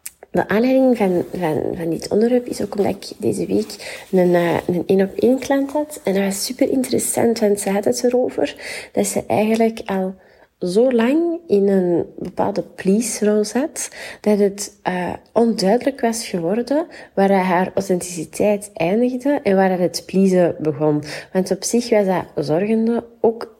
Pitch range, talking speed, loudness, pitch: 185-235 Hz, 165 wpm, -19 LUFS, 205 Hz